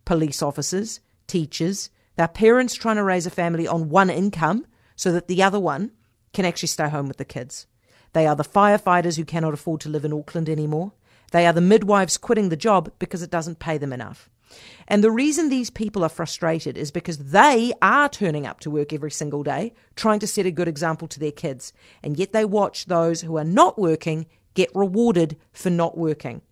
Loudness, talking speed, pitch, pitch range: -21 LUFS, 205 wpm, 170 Hz, 155-200 Hz